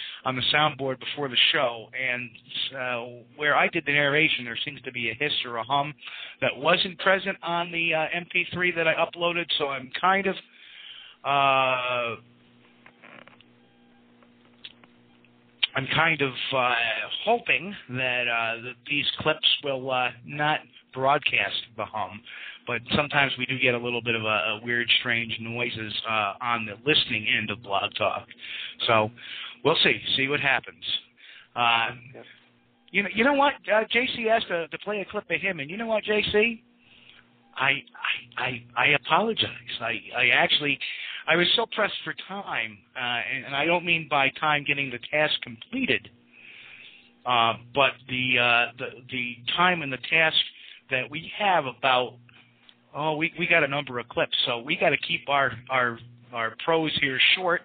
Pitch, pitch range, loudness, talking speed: 135 Hz, 120-165 Hz, -24 LUFS, 165 wpm